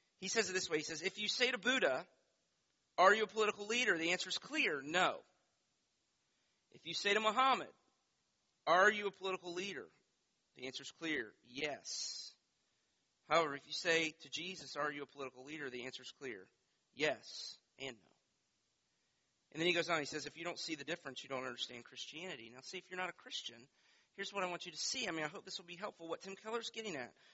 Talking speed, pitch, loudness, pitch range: 215 wpm, 175 Hz, -38 LUFS, 150-195 Hz